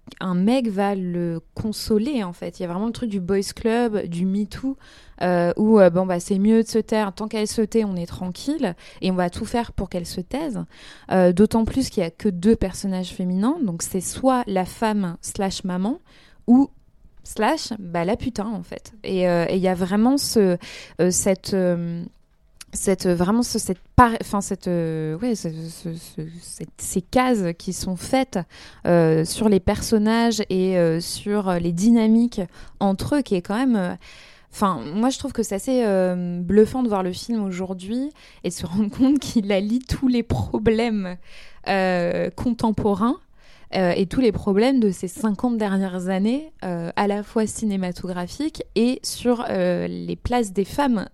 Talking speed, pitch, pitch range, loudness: 170 wpm, 200 Hz, 180-230 Hz, -22 LUFS